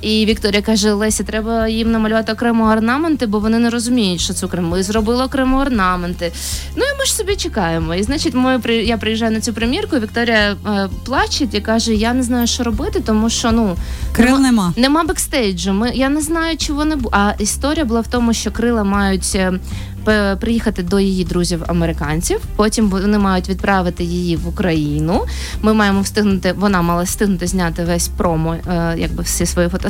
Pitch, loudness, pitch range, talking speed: 215 Hz, -16 LUFS, 185-235 Hz, 185 wpm